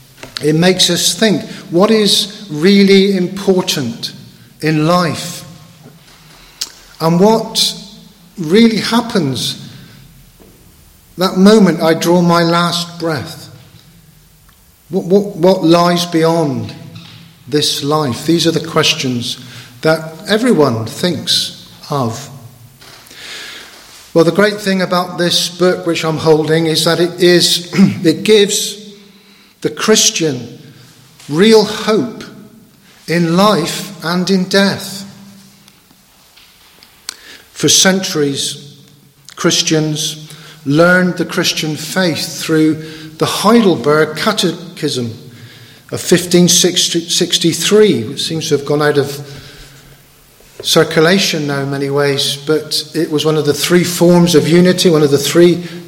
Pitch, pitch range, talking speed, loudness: 165 Hz, 150-185 Hz, 110 wpm, -12 LUFS